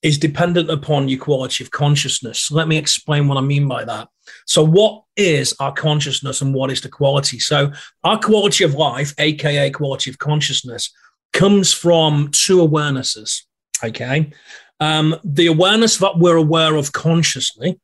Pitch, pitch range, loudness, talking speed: 150 Hz, 140-165 Hz, -16 LUFS, 160 wpm